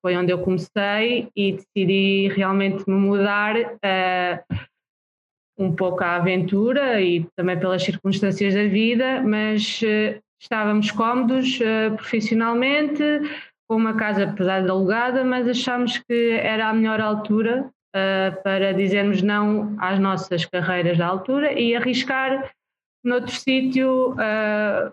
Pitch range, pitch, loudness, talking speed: 195-245 Hz, 210 Hz, -21 LUFS, 130 wpm